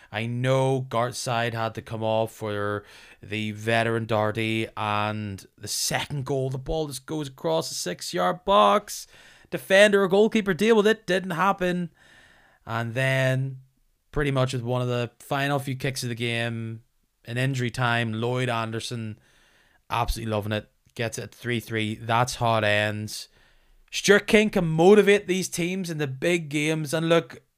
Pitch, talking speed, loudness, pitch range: 130 Hz, 165 wpm, -24 LUFS, 115-165 Hz